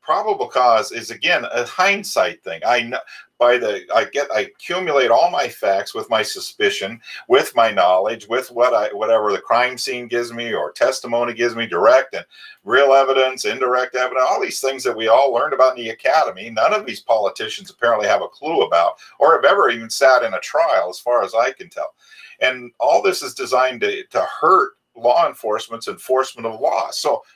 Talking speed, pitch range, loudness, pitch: 195 wpm, 120-145 Hz, -18 LUFS, 130 Hz